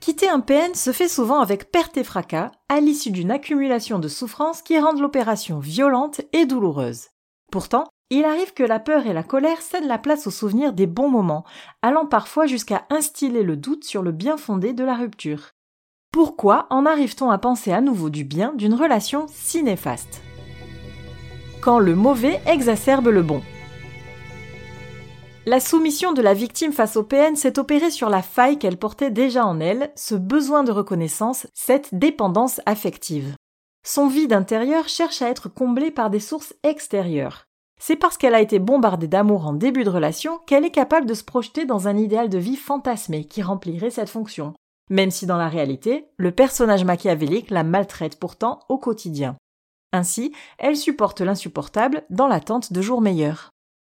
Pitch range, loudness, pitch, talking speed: 190-285 Hz, -20 LUFS, 235 Hz, 175 wpm